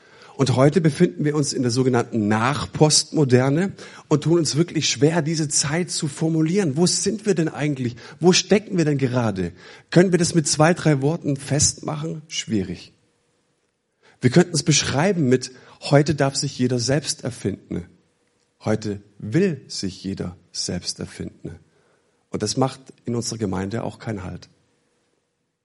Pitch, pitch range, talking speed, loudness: 145 Hz, 125-165 Hz, 145 wpm, -21 LUFS